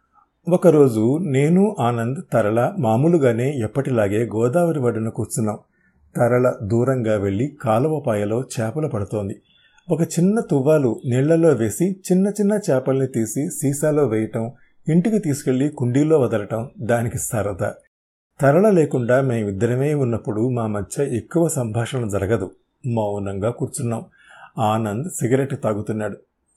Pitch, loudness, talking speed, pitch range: 125 Hz, -20 LUFS, 105 wpm, 110-150 Hz